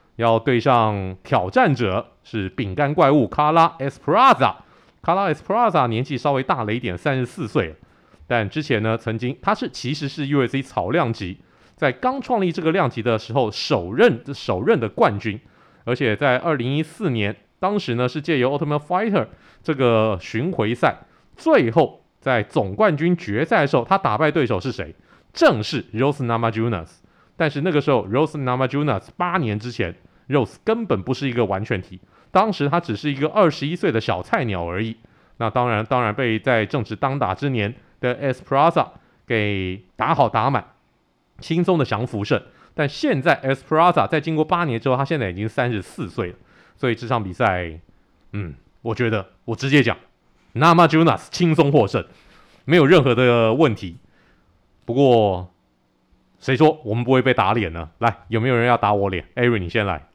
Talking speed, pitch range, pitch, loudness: 315 characters per minute, 105-145 Hz, 120 Hz, -20 LUFS